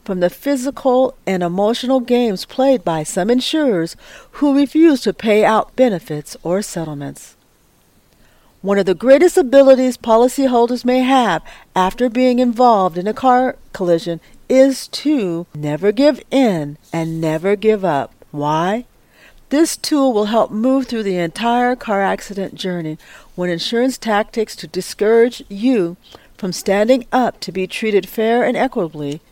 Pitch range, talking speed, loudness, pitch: 180-255 Hz, 140 wpm, -16 LUFS, 220 Hz